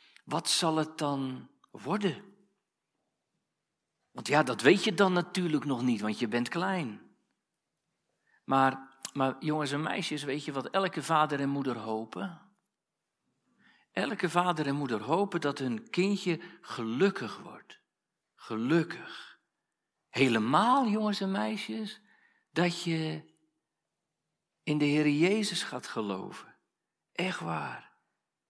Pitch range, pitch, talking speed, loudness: 145-195 Hz, 165 Hz, 120 wpm, -30 LUFS